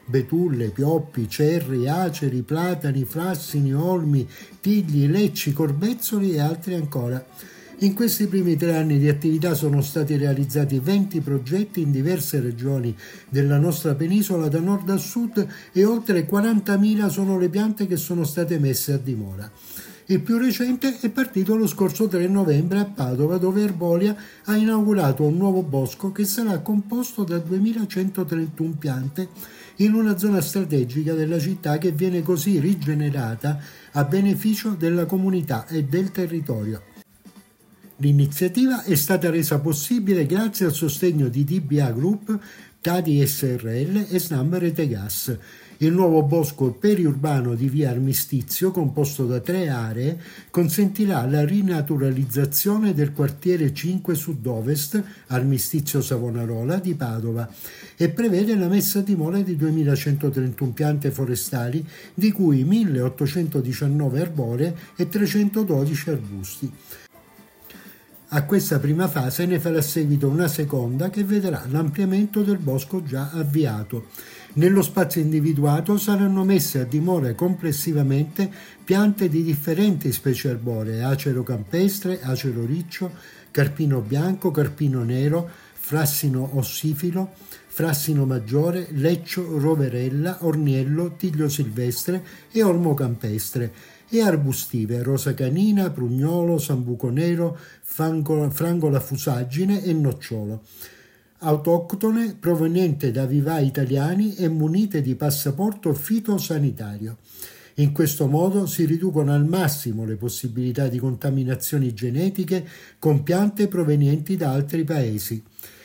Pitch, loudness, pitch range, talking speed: 160 Hz, -22 LUFS, 140-185 Hz, 120 wpm